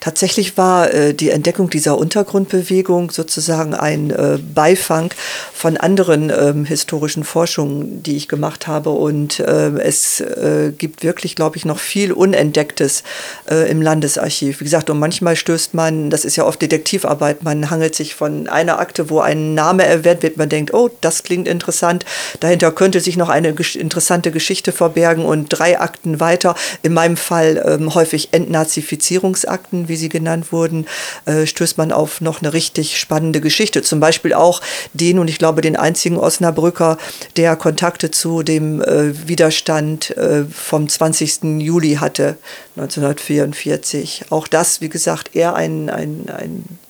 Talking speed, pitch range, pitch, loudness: 145 wpm, 155-170 Hz, 160 Hz, -15 LUFS